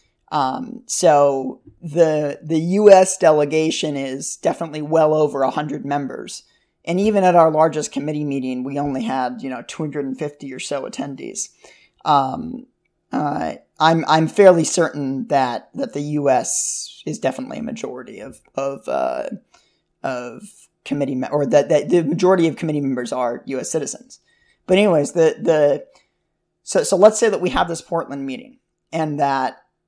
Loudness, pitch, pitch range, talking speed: -19 LUFS, 155 Hz, 140-170 Hz, 155 wpm